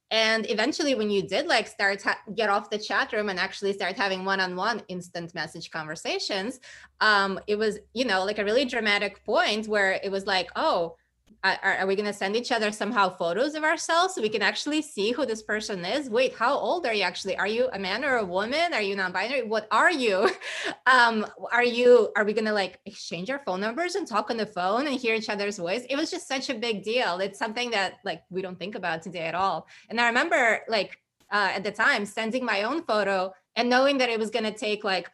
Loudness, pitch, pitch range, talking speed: -26 LUFS, 210 Hz, 190-245 Hz, 235 wpm